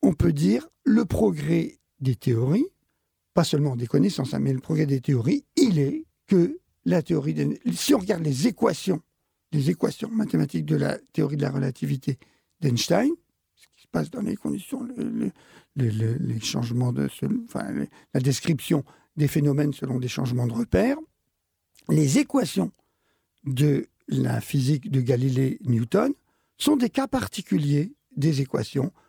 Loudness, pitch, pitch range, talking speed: -25 LUFS, 150 Hz, 130-215 Hz, 155 wpm